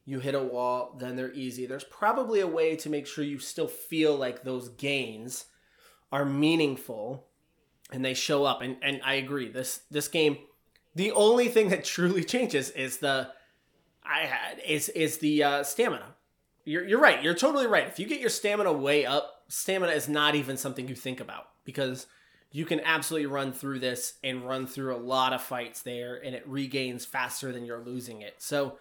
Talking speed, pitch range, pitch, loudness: 195 wpm, 130-150 Hz, 140 Hz, -28 LUFS